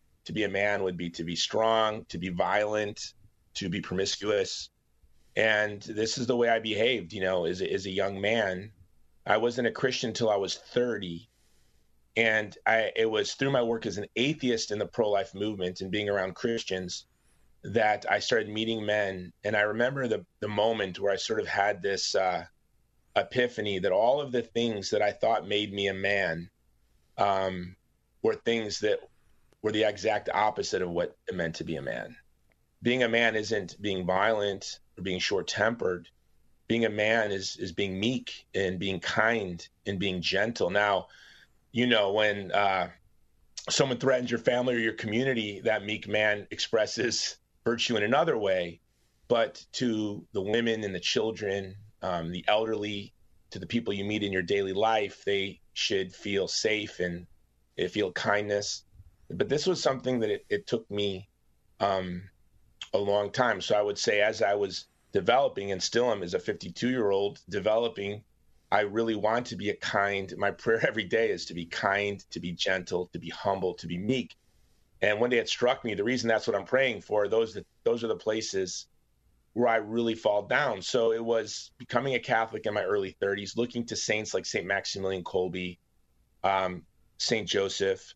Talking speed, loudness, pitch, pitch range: 185 wpm, -29 LUFS, 105 Hz, 95-115 Hz